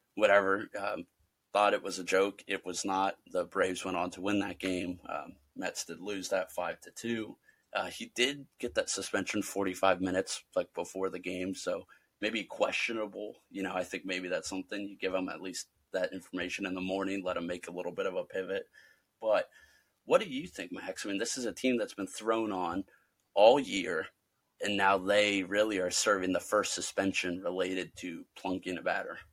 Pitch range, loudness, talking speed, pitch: 95-105 Hz, -33 LUFS, 205 wpm, 95 Hz